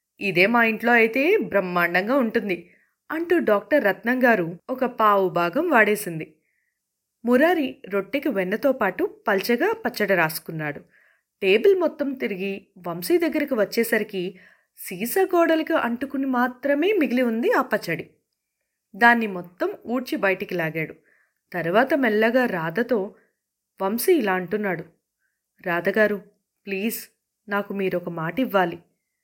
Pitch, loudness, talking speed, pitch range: 220 Hz, -22 LUFS, 105 wpm, 190-270 Hz